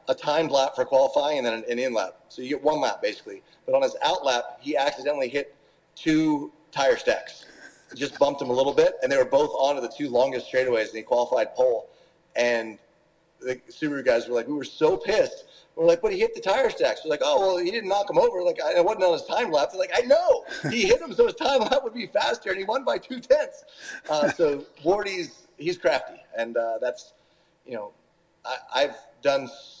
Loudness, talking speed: -24 LUFS, 235 wpm